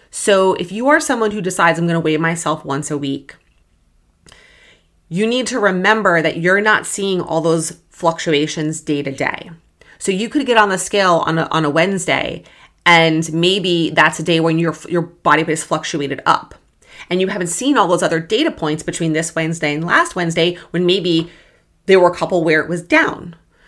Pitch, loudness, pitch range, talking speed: 165 Hz, -16 LUFS, 155-185 Hz, 200 wpm